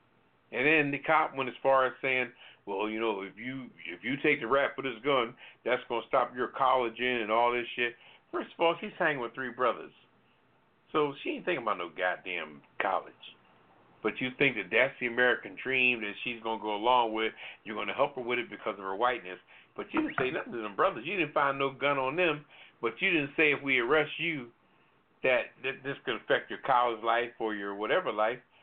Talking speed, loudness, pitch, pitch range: 230 wpm, -30 LUFS, 125 Hz, 115-140 Hz